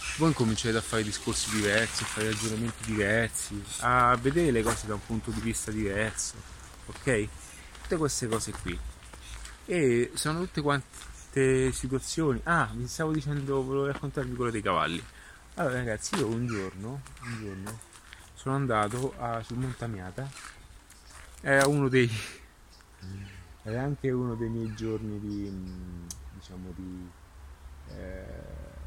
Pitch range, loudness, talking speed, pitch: 95-125 Hz, -29 LUFS, 135 wpm, 110 Hz